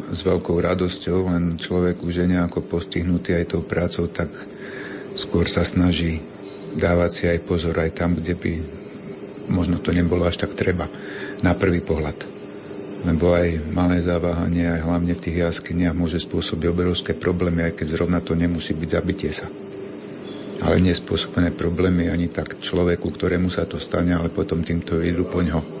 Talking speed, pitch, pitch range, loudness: 165 wpm, 85 Hz, 85-90 Hz, -22 LUFS